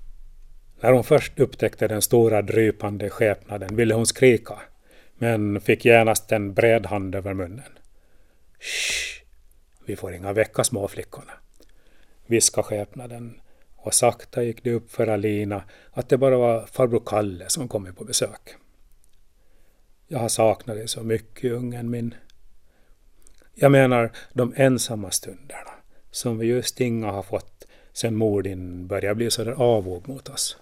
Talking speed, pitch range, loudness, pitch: 145 wpm, 100-120 Hz, -22 LUFS, 115 Hz